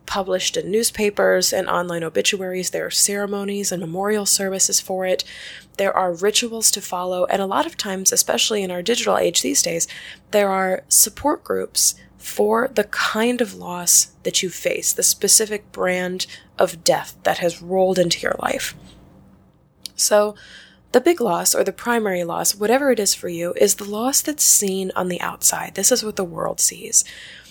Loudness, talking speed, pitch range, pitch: -19 LUFS, 175 wpm, 185-220 Hz, 200 Hz